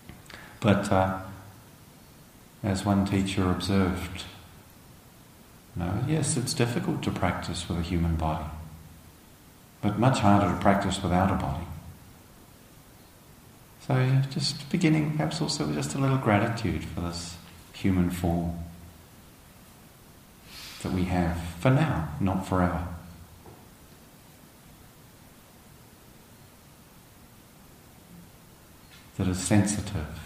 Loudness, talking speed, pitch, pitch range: -27 LUFS, 95 wpm, 95 Hz, 85-115 Hz